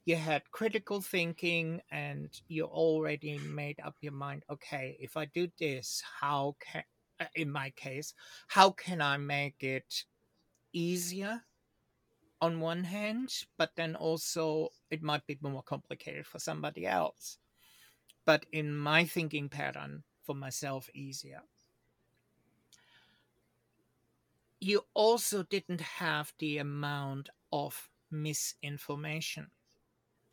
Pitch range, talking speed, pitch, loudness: 140-170 Hz, 115 wpm, 150 Hz, -35 LUFS